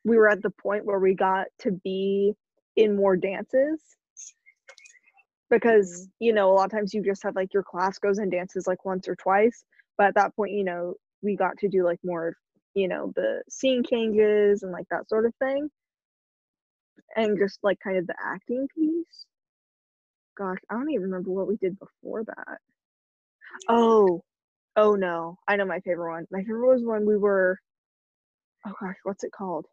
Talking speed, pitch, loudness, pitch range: 190 wpm, 200 Hz, -25 LUFS, 190-230 Hz